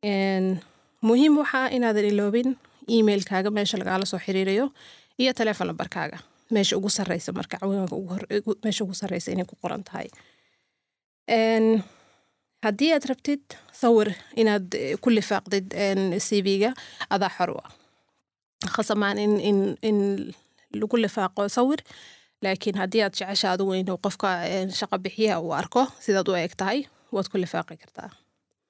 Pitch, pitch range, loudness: 205 Hz, 190-225 Hz, -25 LUFS